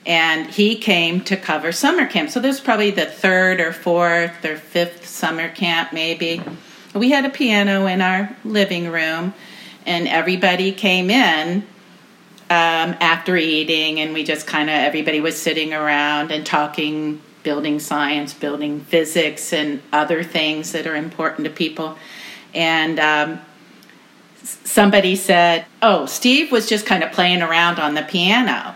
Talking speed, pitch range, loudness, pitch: 150 wpm, 155-190 Hz, -17 LUFS, 170 Hz